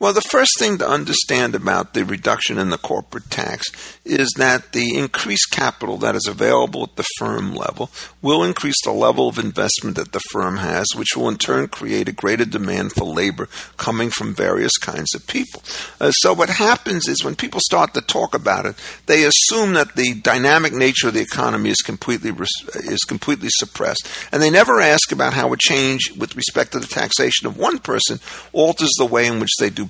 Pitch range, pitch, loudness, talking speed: 115-145 Hz, 130 Hz, -17 LUFS, 205 wpm